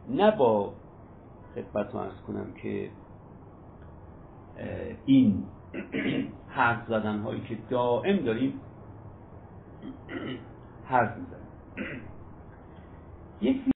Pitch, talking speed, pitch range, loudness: 110 Hz, 75 wpm, 100-125 Hz, -29 LUFS